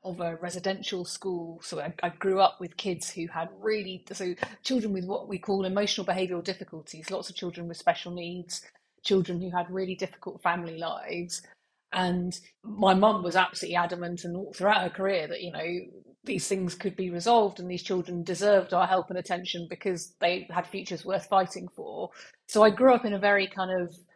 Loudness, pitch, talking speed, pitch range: -29 LUFS, 185 Hz, 195 wpm, 175-195 Hz